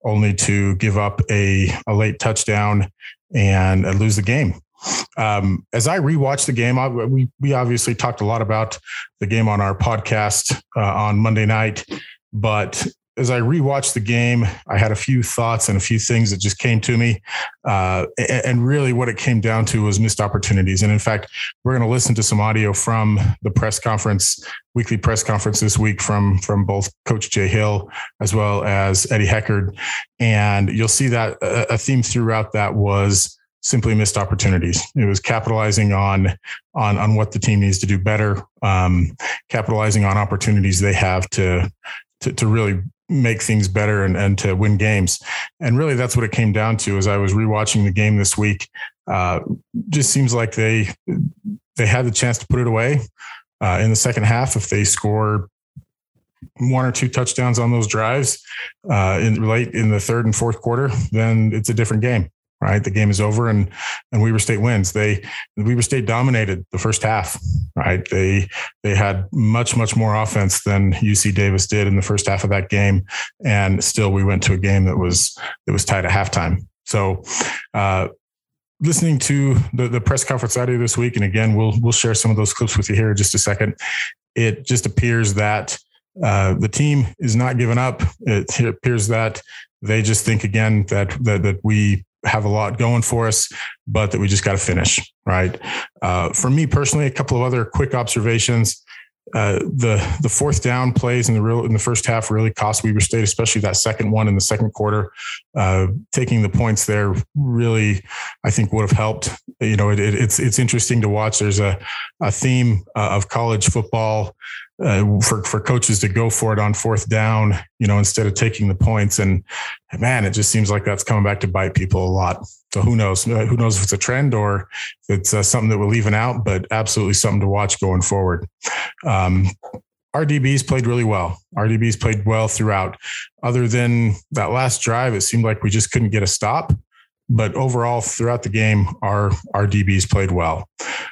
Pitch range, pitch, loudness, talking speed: 100-120 Hz, 110 Hz, -18 LUFS, 195 wpm